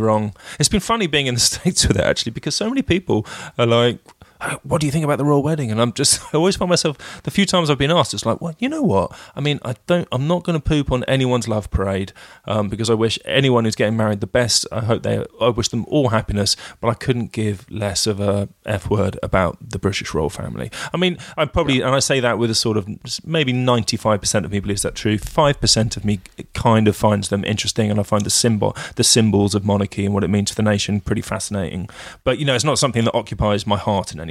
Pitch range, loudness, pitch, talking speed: 105-145 Hz, -19 LUFS, 115 Hz, 255 wpm